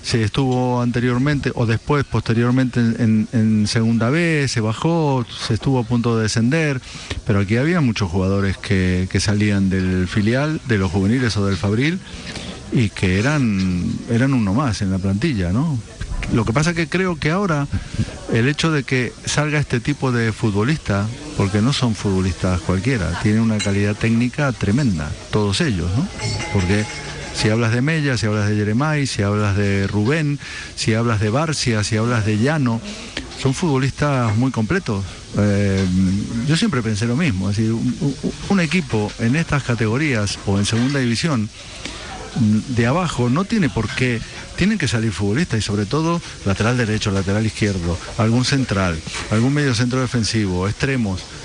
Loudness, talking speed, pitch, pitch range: -19 LUFS, 165 wpm, 115 Hz, 105-135 Hz